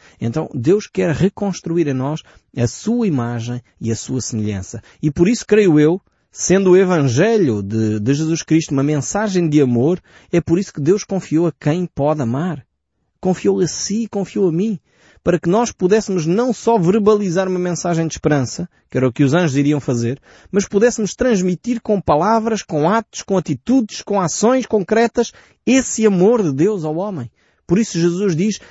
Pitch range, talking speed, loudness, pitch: 145-205 Hz, 180 wpm, -17 LUFS, 175 Hz